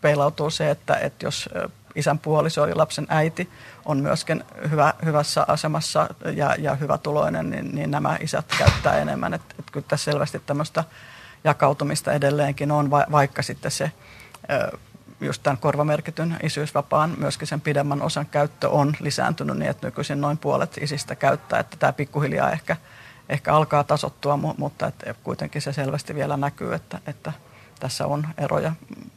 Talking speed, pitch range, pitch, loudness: 150 wpm, 145-155 Hz, 145 Hz, -23 LUFS